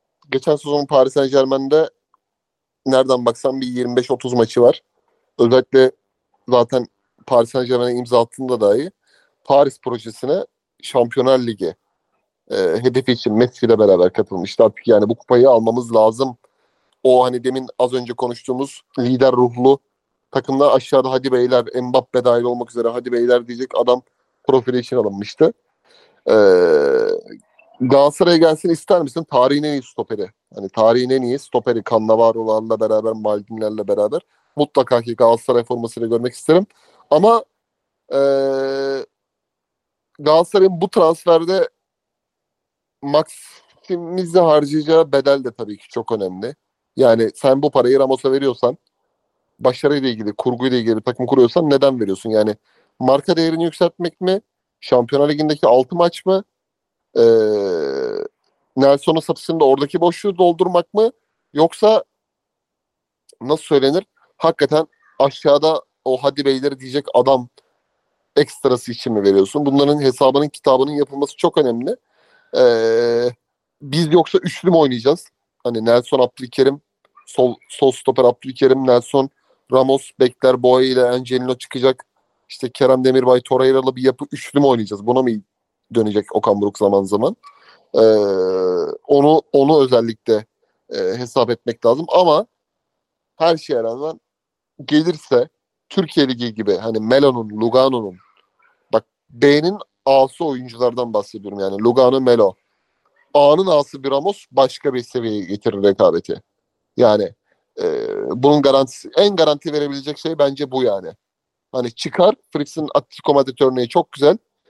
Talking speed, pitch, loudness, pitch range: 125 wpm, 135 Hz, -16 LUFS, 125-160 Hz